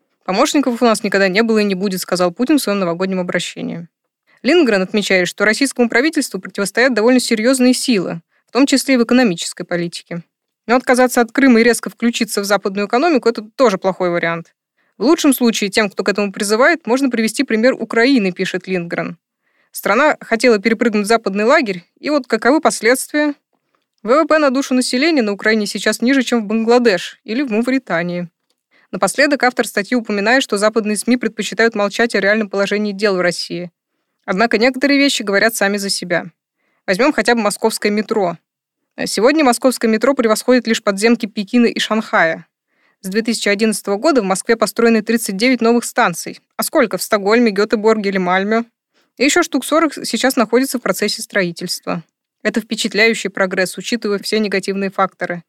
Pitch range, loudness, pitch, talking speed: 200-245 Hz, -15 LUFS, 225 Hz, 165 wpm